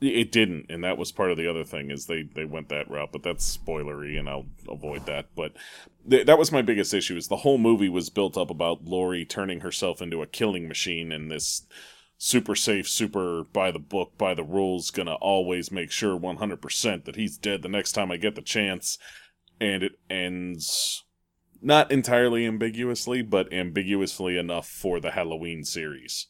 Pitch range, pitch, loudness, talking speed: 80-105 Hz, 90 Hz, -26 LUFS, 190 wpm